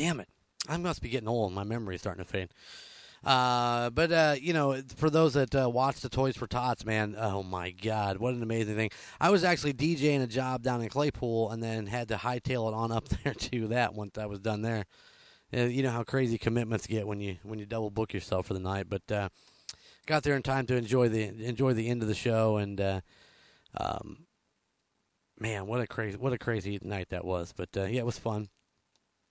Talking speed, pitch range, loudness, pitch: 230 wpm, 105-130 Hz, -31 LUFS, 115 Hz